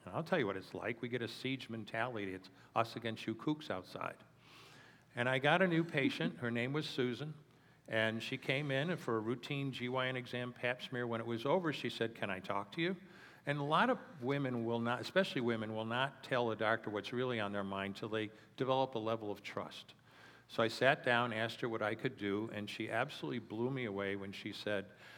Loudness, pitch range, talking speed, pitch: -38 LUFS, 110-135 Hz, 225 wpm, 120 Hz